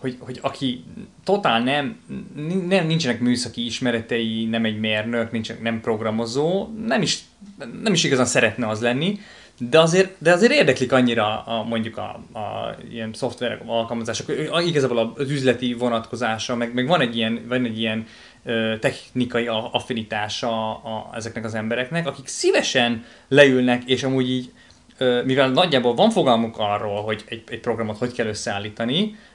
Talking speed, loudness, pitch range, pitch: 145 wpm, -21 LUFS, 115-140 Hz, 120 Hz